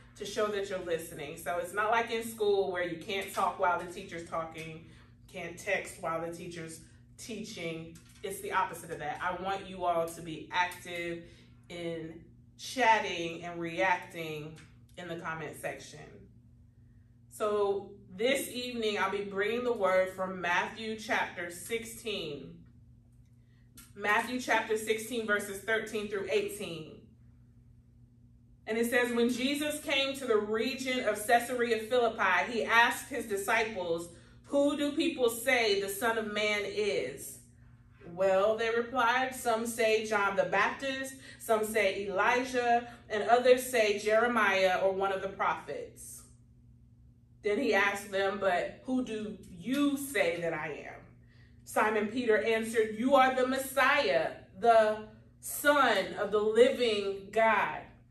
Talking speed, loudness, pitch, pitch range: 140 wpm, -31 LUFS, 200 Hz, 170-230 Hz